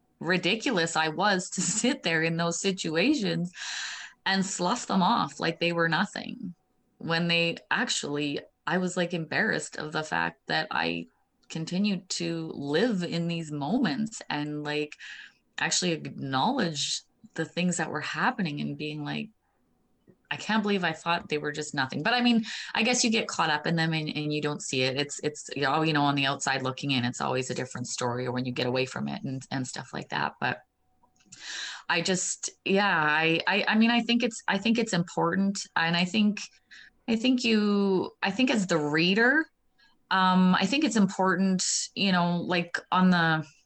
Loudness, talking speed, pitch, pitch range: -27 LUFS, 190 wpm, 170 Hz, 150-200 Hz